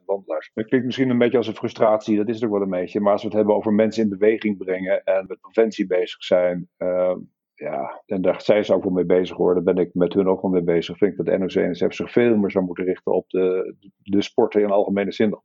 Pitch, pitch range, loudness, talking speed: 100 Hz, 90-110 Hz, -21 LUFS, 270 wpm